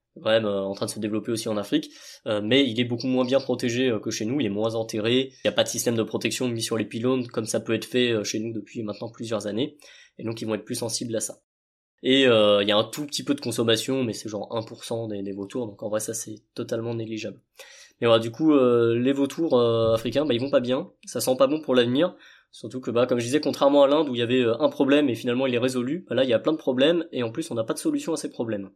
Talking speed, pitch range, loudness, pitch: 300 wpm, 110-130 Hz, -24 LUFS, 120 Hz